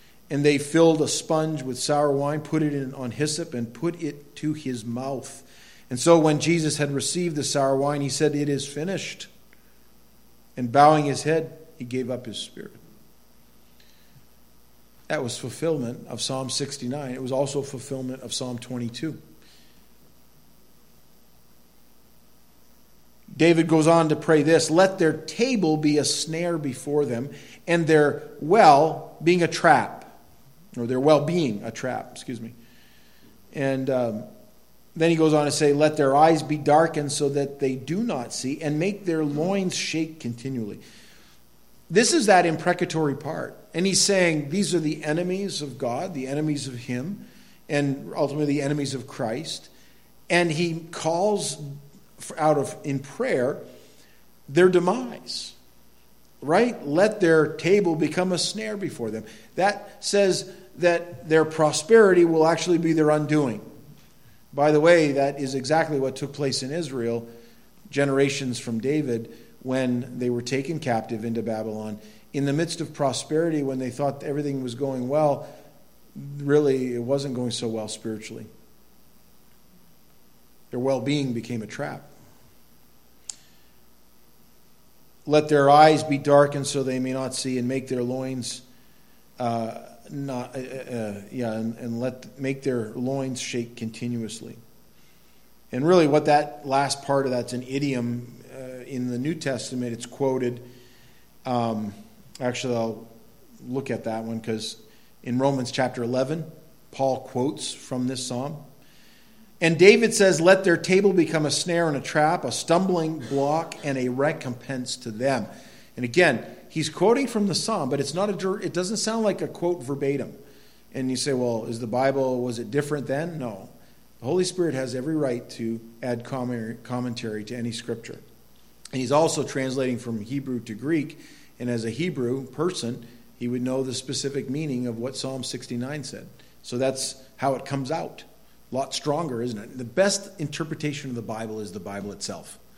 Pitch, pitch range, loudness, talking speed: 140 Hz, 125-160 Hz, -24 LUFS, 155 wpm